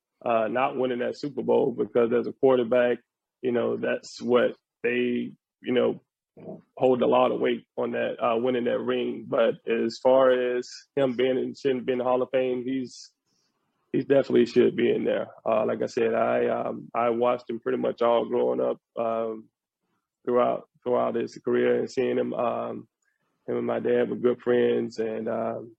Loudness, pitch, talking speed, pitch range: -26 LUFS, 120 Hz, 185 wpm, 115-125 Hz